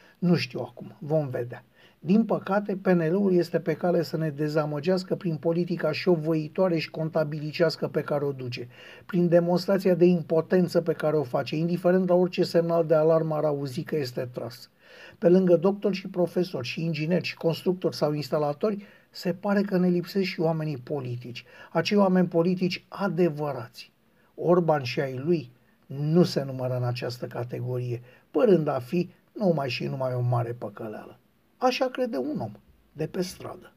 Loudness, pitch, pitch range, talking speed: -26 LUFS, 165 Hz, 145-180 Hz, 165 wpm